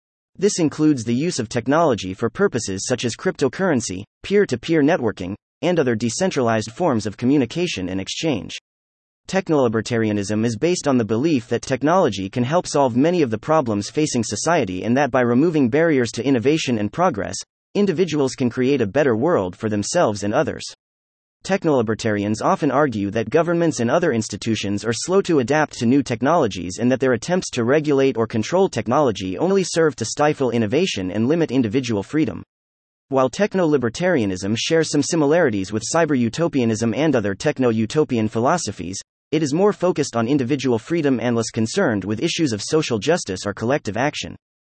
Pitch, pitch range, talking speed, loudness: 120 Hz, 110-150 Hz, 165 wpm, -20 LUFS